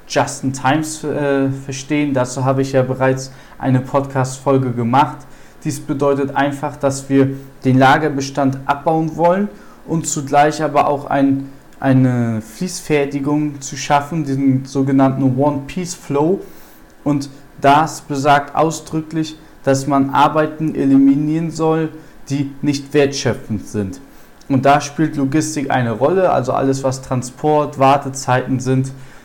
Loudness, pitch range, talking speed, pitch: -17 LUFS, 135-150 Hz, 120 wpm, 140 Hz